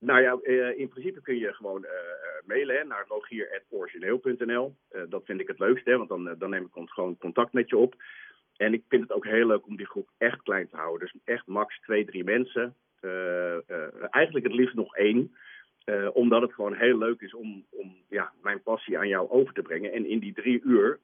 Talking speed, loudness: 210 wpm, -28 LUFS